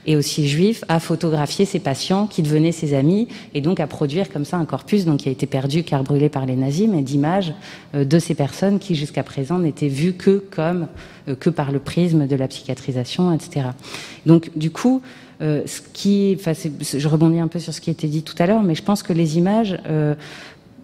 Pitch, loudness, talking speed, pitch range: 160 Hz, -20 LUFS, 215 wpm, 145-180 Hz